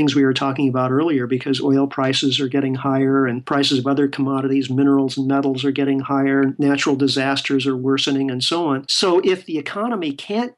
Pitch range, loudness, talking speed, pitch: 135-140 Hz, -19 LUFS, 195 wpm, 140 Hz